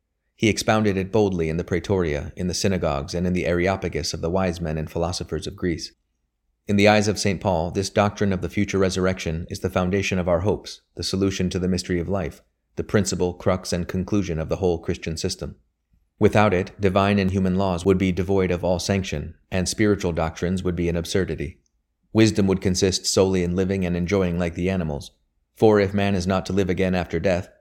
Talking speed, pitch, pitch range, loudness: 210 wpm, 90 Hz, 85-95 Hz, -23 LUFS